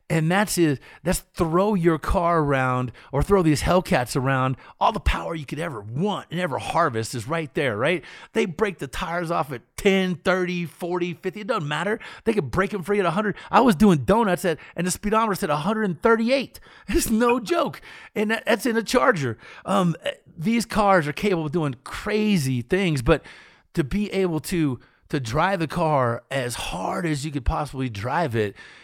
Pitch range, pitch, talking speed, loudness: 150-205 Hz, 175 Hz, 190 wpm, -23 LUFS